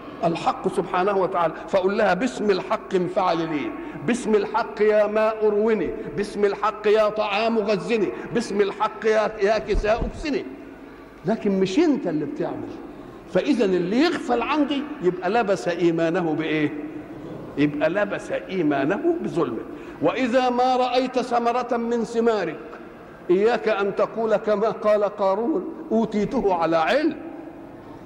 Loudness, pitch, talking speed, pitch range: -23 LUFS, 215 Hz, 120 wpm, 195-255 Hz